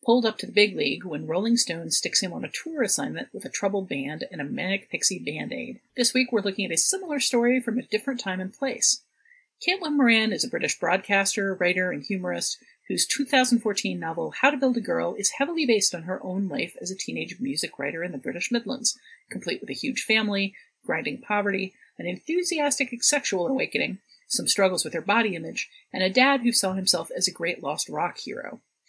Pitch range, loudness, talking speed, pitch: 195-260 Hz, -24 LUFS, 210 wpm, 230 Hz